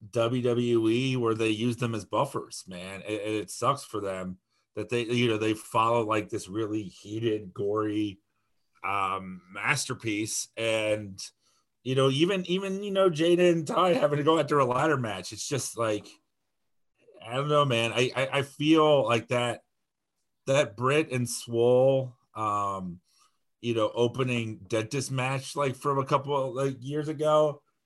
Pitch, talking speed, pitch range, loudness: 120 Hz, 160 wpm, 110-140 Hz, -27 LUFS